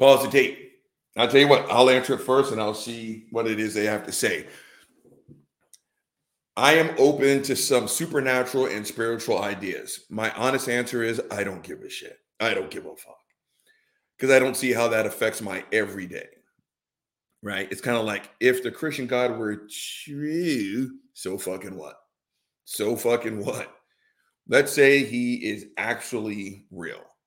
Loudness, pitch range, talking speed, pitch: -23 LUFS, 110-150 Hz, 165 wpm, 125 Hz